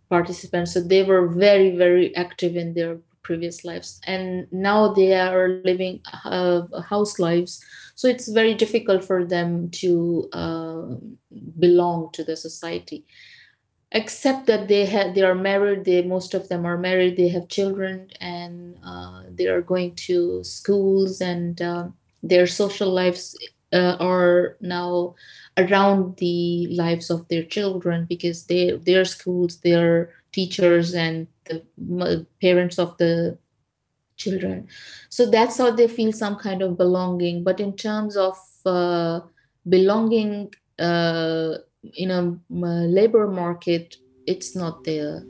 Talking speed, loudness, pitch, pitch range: 135 wpm, -21 LUFS, 180 Hz, 175-195 Hz